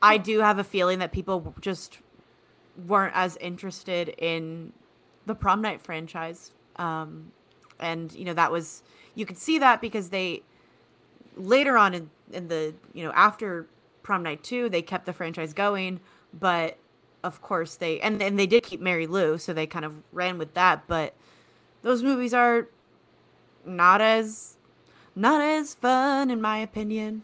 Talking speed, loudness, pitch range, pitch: 165 wpm, -25 LUFS, 170-215 Hz, 185 Hz